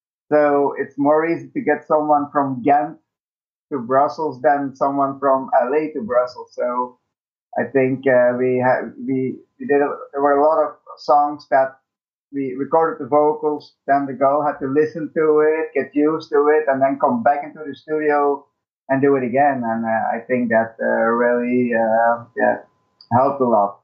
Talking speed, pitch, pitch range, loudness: 185 wpm, 140 Hz, 125-150 Hz, -19 LUFS